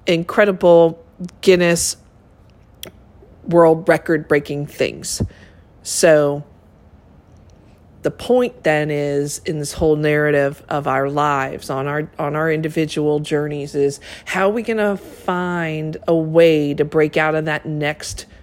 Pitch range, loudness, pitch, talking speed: 140-165 Hz, -18 LUFS, 150 Hz, 125 wpm